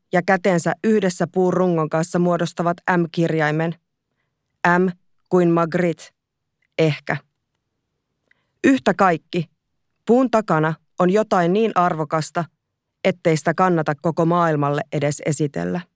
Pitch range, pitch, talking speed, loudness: 155-180 Hz, 170 Hz, 100 wpm, -20 LUFS